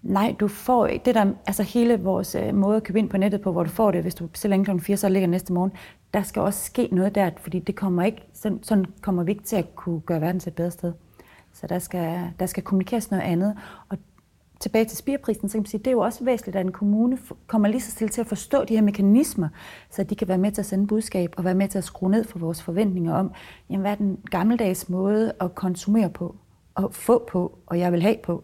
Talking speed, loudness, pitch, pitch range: 265 wpm, -24 LUFS, 195 Hz, 180-215 Hz